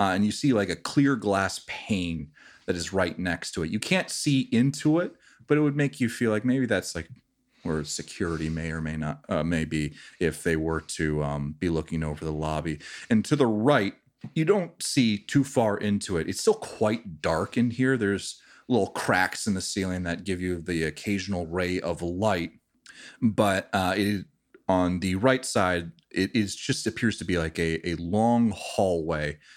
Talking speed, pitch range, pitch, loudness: 195 wpm, 80-115 Hz, 95 Hz, -27 LUFS